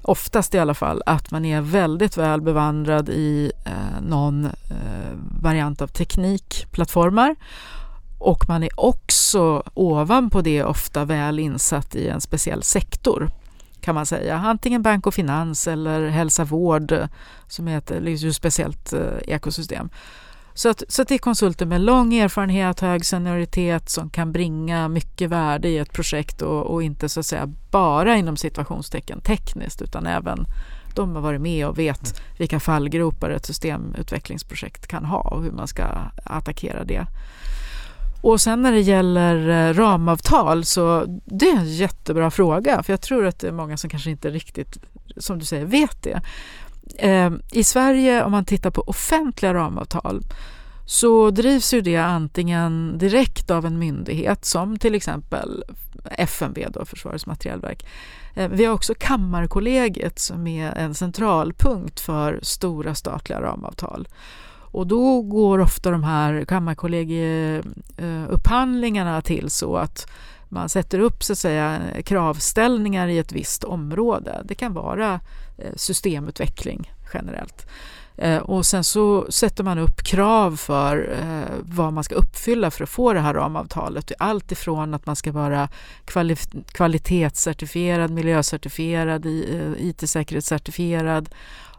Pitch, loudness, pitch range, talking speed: 170 Hz, -21 LUFS, 155-200 Hz, 135 wpm